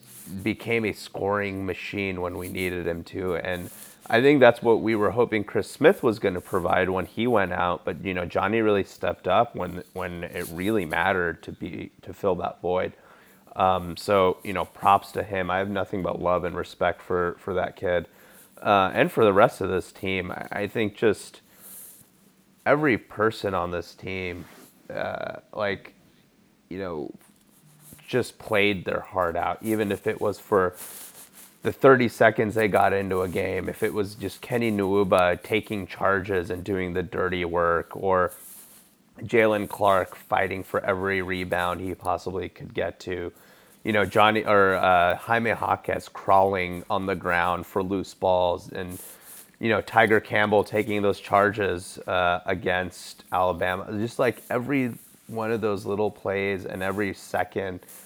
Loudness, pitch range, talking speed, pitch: -25 LUFS, 90-105 Hz, 170 wpm, 95 Hz